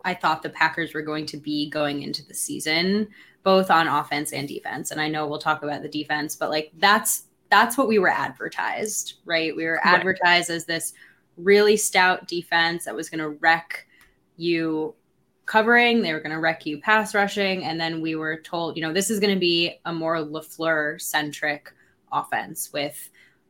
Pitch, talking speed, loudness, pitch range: 165 Hz, 190 wpm, -23 LUFS, 155-185 Hz